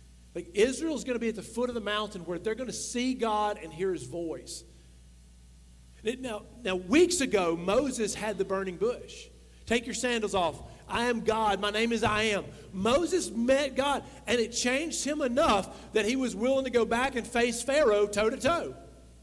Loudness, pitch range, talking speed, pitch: -29 LUFS, 195-250 Hz, 200 wpm, 220 Hz